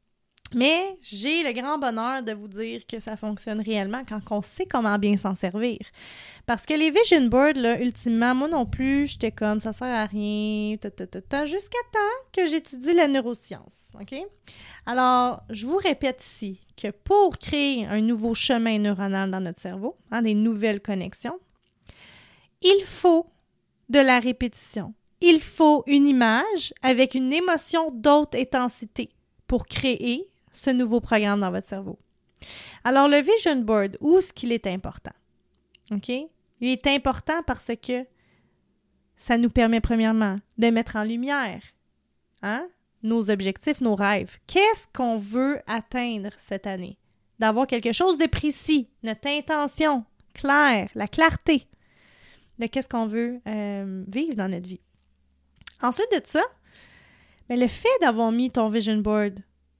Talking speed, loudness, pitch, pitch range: 150 wpm, -23 LUFS, 240 Hz, 215-290 Hz